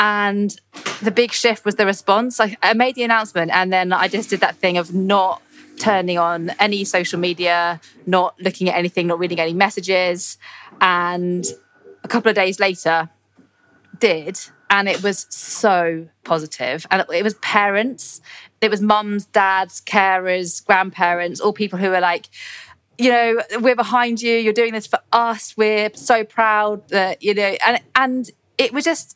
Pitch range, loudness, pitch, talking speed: 180-220 Hz, -18 LUFS, 195 Hz, 170 wpm